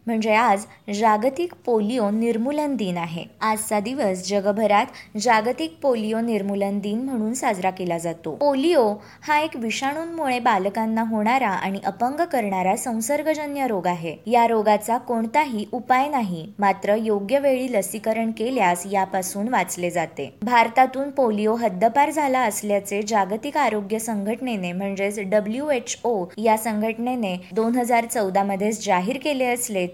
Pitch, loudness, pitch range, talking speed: 220 Hz, -22 LUFS, 200-250 Hz, 125 wpm